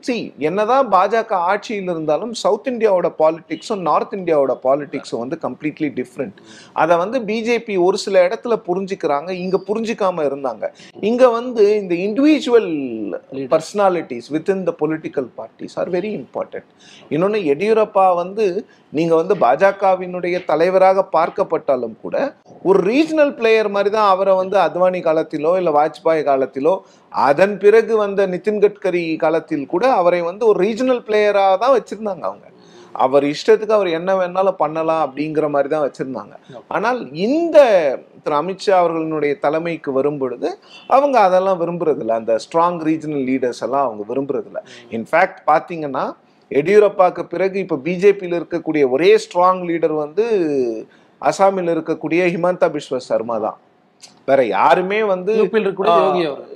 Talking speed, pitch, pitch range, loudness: 130 wpm, 185 Hz, 155-210 Hz, -17 LUFS